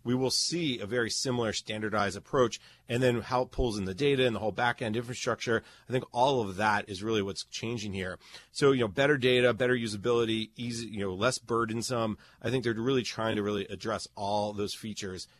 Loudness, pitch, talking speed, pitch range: -30 LUFS, 115 Hz, 210 wpm, 105-125 Hz